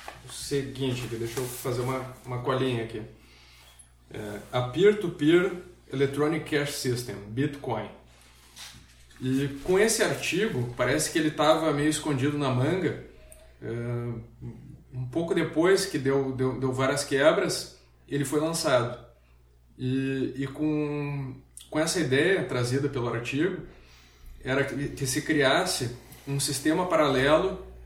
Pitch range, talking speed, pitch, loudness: 120-145 Hz, 125 wpm, 130 Hz, -27 LUFS